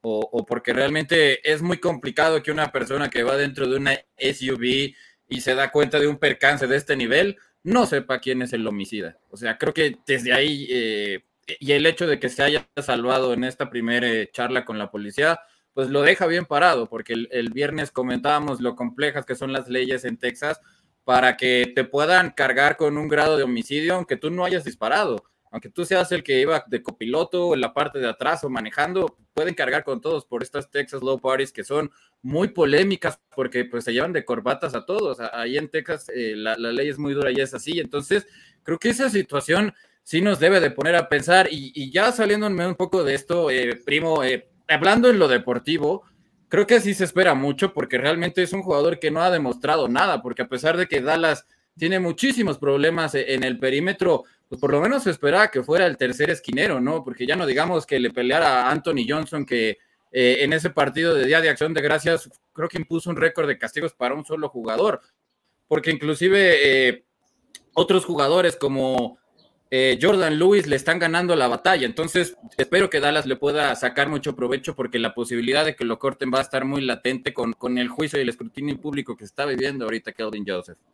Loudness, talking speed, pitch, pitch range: -21 LUFS, 210 wpm, 145 Hz, 125-165 Hz